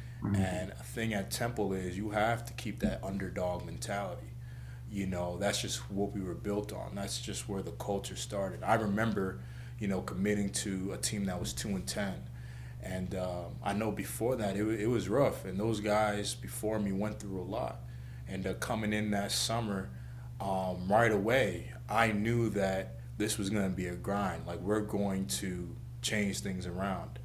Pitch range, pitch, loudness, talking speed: 90-105 Hz, 100 Hz, -34 LUFS, 190 wpm